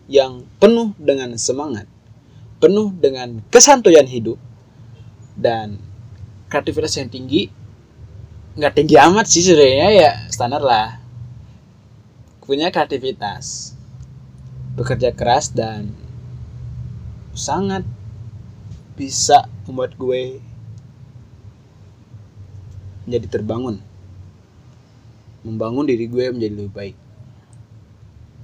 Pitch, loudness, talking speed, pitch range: 120 Hz, -16 LUFS, 80 wpm, 110-130 Hz